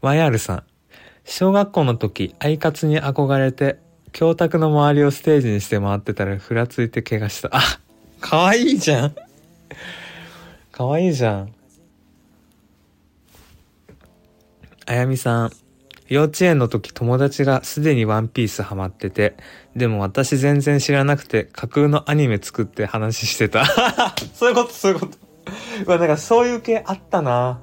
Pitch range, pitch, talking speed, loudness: 110-155 Hz, 135 Hz, 295 characters per minute, -19 LUFS